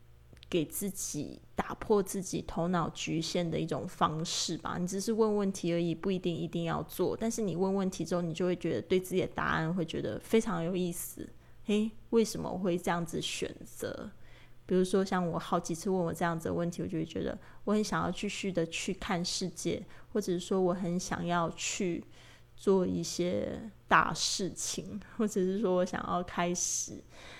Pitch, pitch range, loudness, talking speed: 180 Hz, 170-195 Hz, -33 LUFS, 275 characters per minute